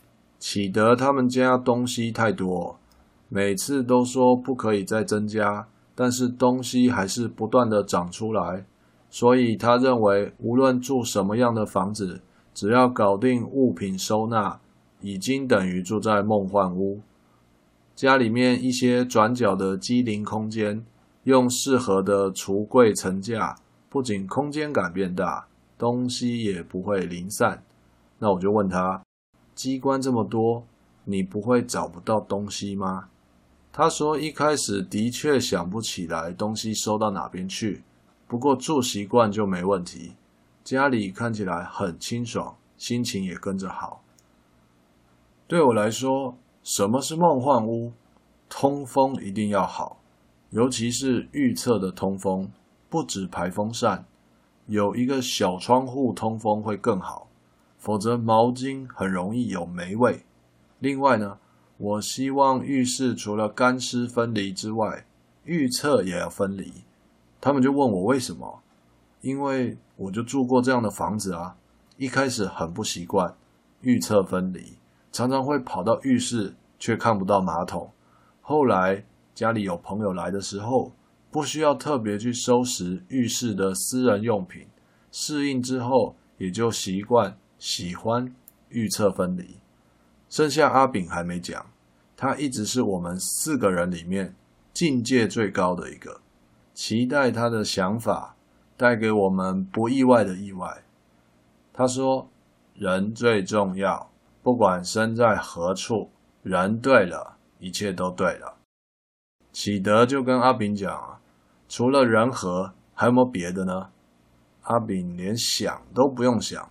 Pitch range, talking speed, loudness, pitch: 90-125 Hz, 205 characters per minute, -24 LUFS, 105 Hz